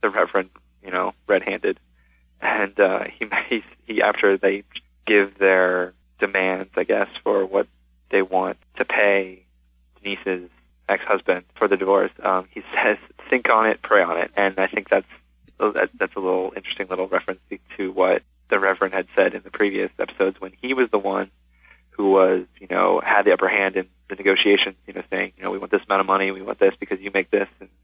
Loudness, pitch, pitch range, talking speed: -21 LUFS, 95 Hz, 60-95 Hz, 205 wpm